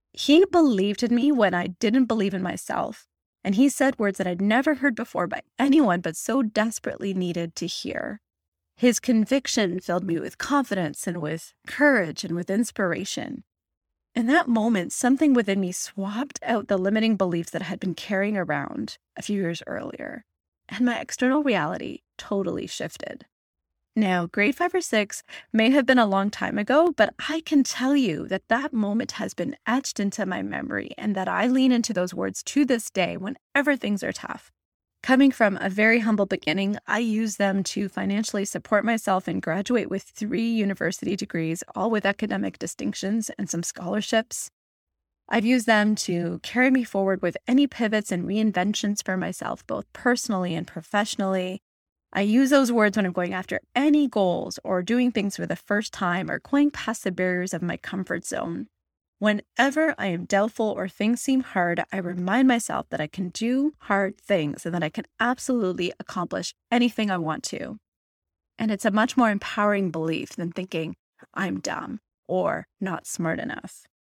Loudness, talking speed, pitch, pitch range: -24 LUFS, 175 wpm, 205 Hz, 185-245 Hz